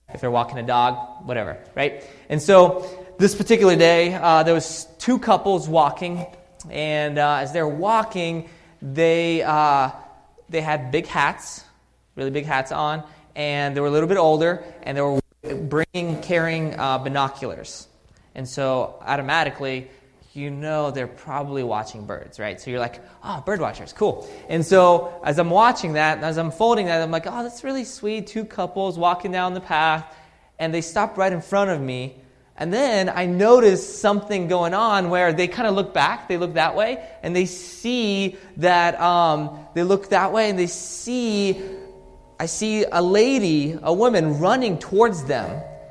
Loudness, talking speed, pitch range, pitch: -21 LUFS, 175 wpm, 145-190 Hz, 165 Hz